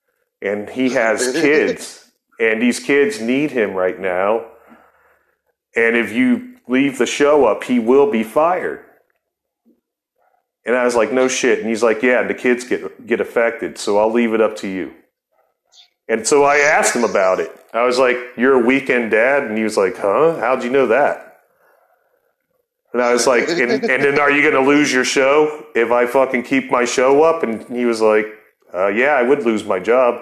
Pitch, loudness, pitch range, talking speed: 125 Hz, -16 LUFS, 115-145 Hz, 195 wpm